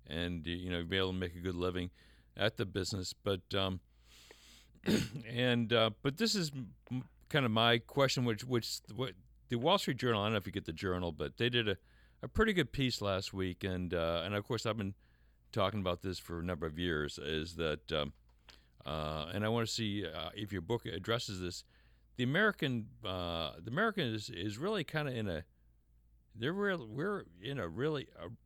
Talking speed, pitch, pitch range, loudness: 210 wpm, 100 Hz, 85-120 Hz, -36 LUFS